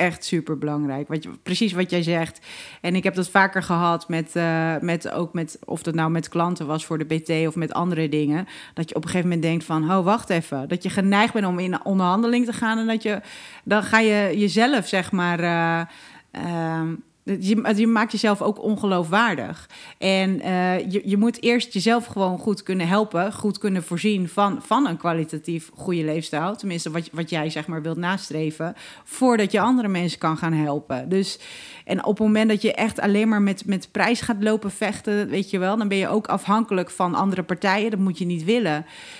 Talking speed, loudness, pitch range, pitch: 210 wpm, -22 LUFS, 165-210 Hz, 185 Hz